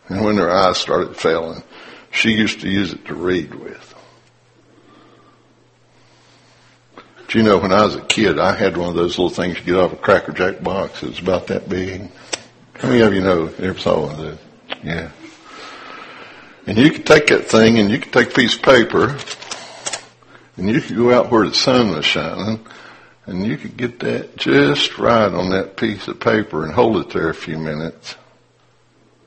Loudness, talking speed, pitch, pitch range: -17 LUFS, 195 wpm, 95 Hz, 85-110 Hz